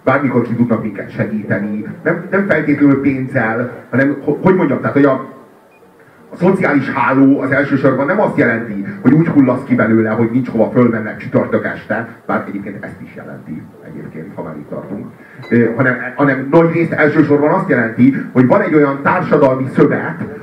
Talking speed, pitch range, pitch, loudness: 170 wpm, 120-150 Hz, 135 Hz, -14 LUFS